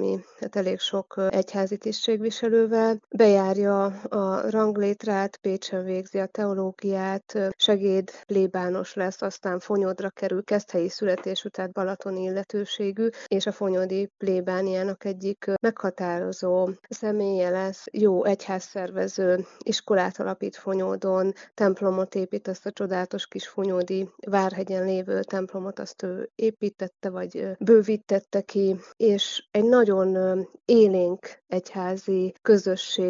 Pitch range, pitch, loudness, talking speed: 190-205 Hz, 195 Hz, -25 LUFS, 105 wpm